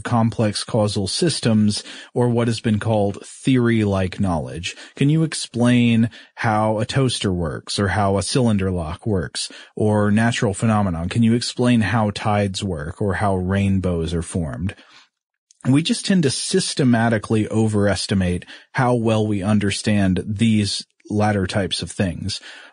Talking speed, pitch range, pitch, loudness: 135 wpm, 100-120 Hz, 105 Hz, -20 LUFS